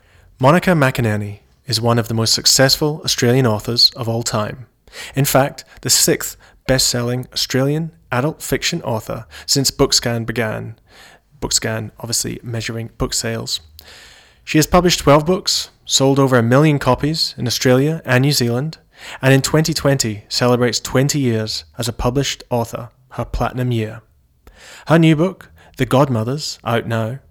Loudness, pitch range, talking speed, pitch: -16 LUFS, 115-140 Hz, 145 wpm, 125 Hz